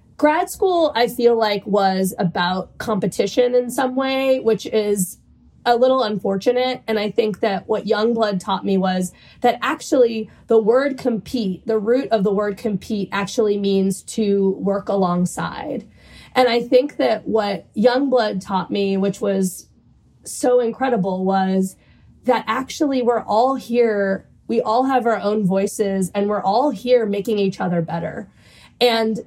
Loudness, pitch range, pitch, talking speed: -19 LUFS, 195-245 Hz, 220 Hz, 150 wpm